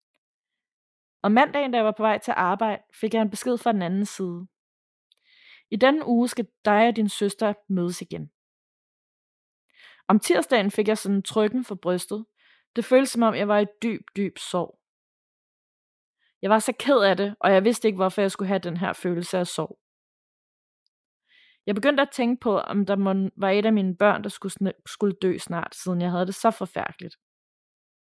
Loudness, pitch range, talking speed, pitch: -24 LUFS, 190-230 Hz, 185 wpm, 205 Hz